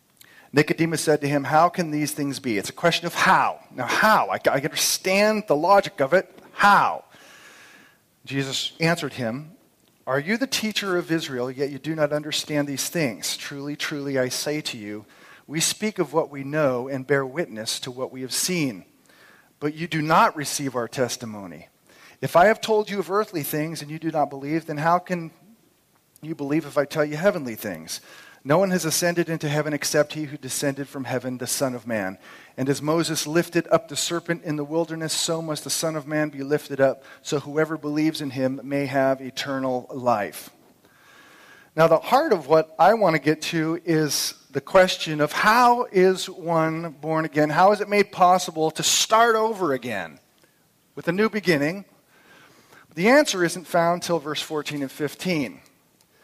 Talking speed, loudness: 185 wpm, -23 LUFS